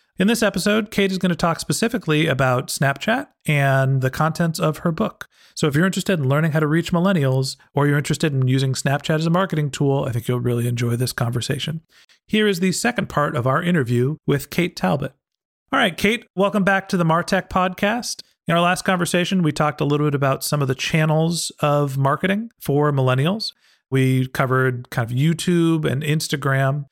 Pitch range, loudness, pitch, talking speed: 135-180 Hz, -20 LUFS, 155 Hz, 200 wpm